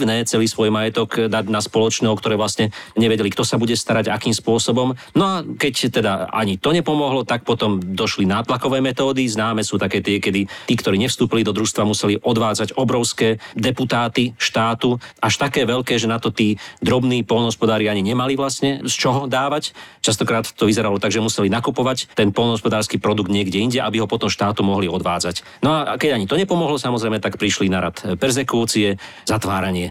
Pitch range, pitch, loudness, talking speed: 105-125 Hz, 115 Hz, -19 LUFS, 180 wpm